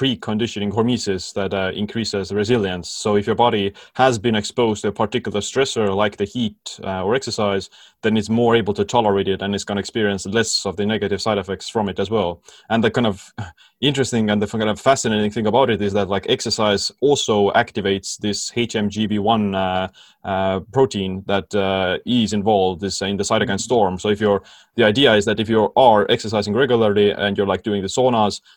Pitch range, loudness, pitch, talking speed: 100-115 Hz, -19 LUFS, 105 Hz, 205 wpm